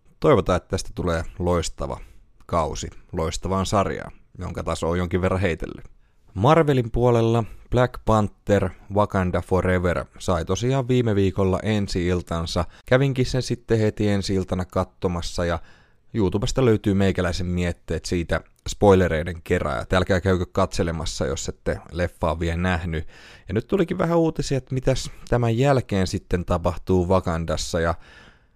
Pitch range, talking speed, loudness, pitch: 90-110 Hz, 130 wpm, -23 LUFS, 95 Hz